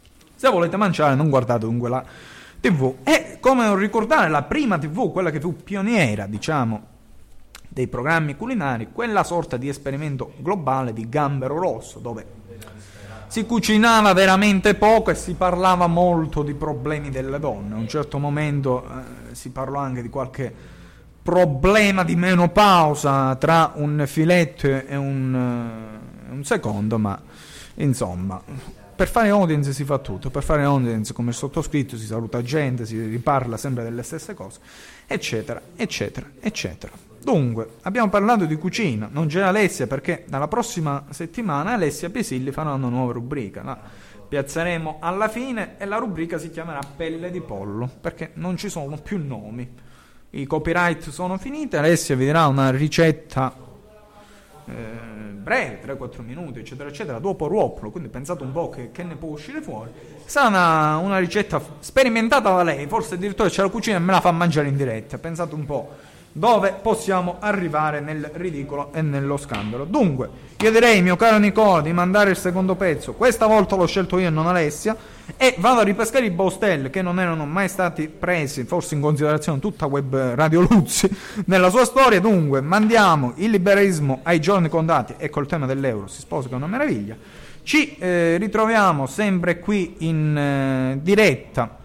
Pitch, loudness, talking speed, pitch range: 160 Hz, -20 LUFS, 160 wpm, 135-190 Hz